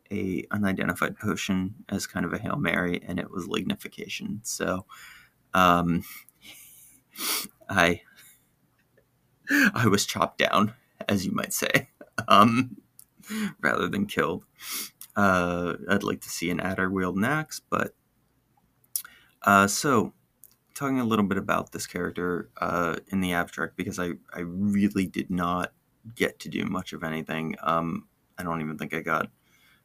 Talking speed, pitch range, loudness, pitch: 140 wpm, 85-100 Hz, -27 LUFS, 95 Hz